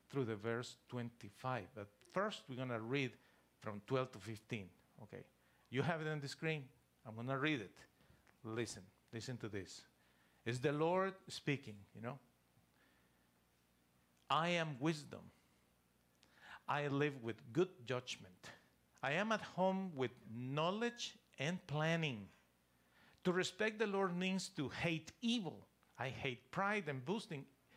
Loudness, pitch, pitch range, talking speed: -42 LUFS, 130 Hz, 105-165 Hz, 135 wpm